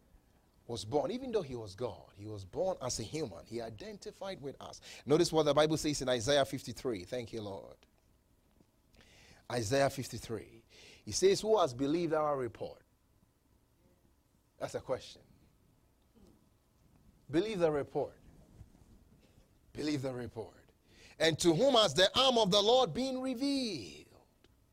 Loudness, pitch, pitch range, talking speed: -33 LUFS, 150 Hz, 120-195 Hz, 140 wpm